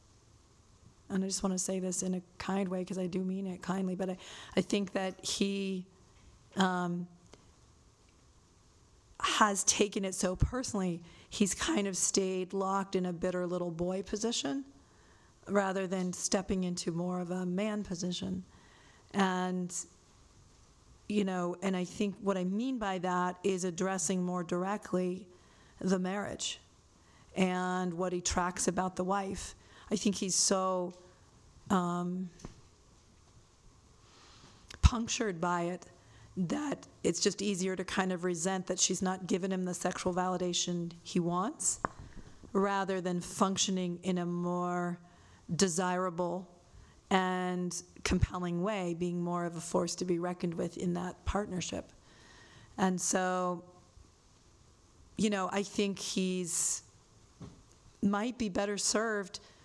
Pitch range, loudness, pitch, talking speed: 175-195 Hz, -33 LUFS, 185 Hz, 135 wpm